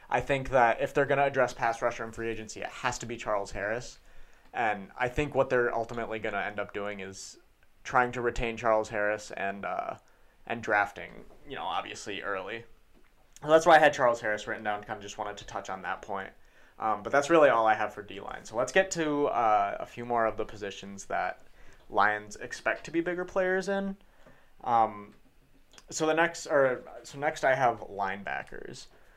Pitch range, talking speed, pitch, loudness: 105-140 Hz, 210 wpm, 115 Hz, -29 LUFS